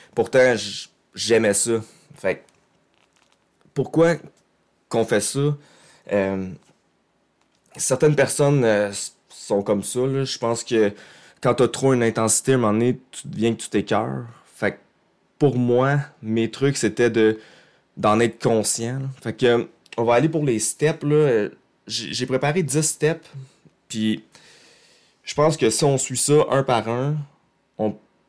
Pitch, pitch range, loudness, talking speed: 125 Hz, 110-145 Hz, -21 LUFS, 145 wpm